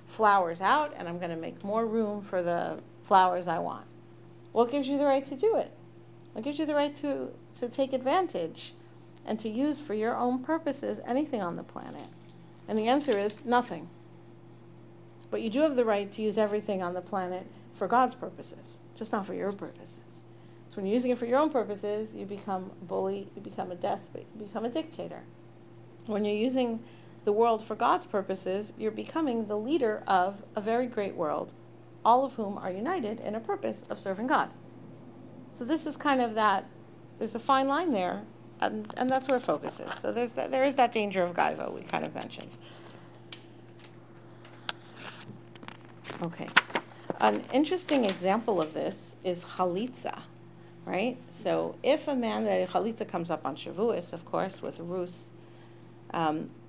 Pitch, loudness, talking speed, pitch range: 205 Hz, -30 LUFS, 180 wpm, 165-250 Hz